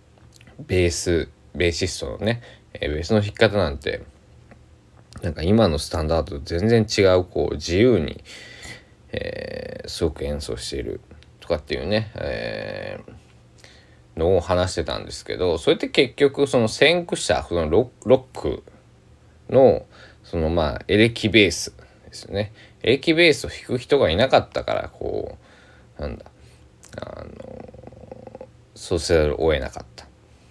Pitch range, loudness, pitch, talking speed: 80-110 Hz, -21 LUFS, 95 Hz, 240 characters per minute